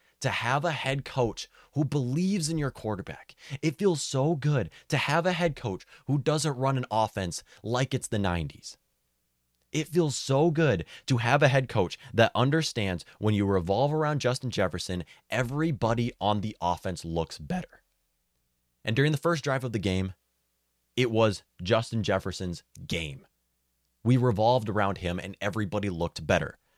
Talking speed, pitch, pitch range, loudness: 160 wpm, 115 Hz, 90-140 Hz, -28 LUFS